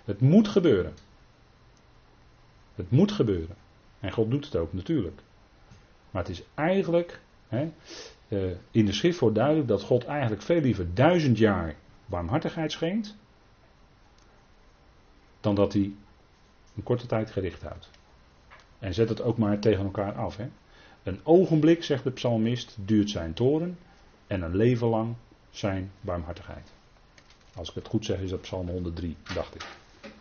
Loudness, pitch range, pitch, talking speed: -27 LUFS, 95-135 Hz, 110 Hz, 145 wpm